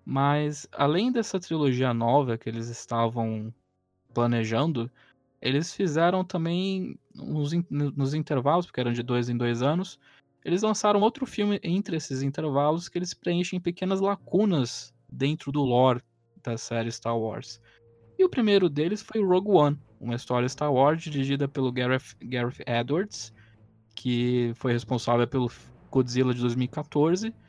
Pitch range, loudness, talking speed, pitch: 120-170 Hz, -27 LUFS, 140 wpm, 135 Hz